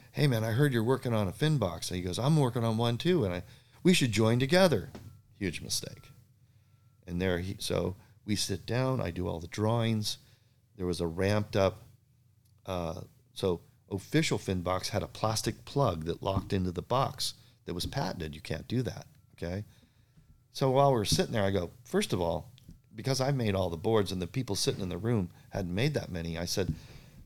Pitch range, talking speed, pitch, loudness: 95-125 Hz, 205 wpm, 115 Hz, -31 LUFS